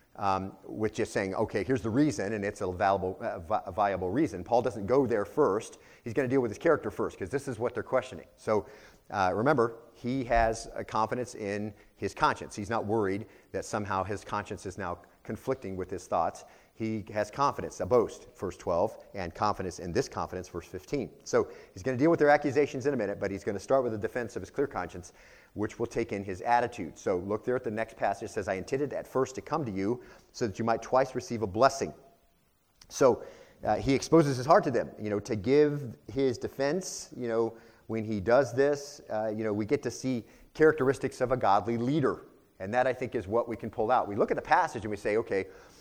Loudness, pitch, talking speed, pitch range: -30 LUFS, 115 Hz, 230 wpm, 105-130 Hz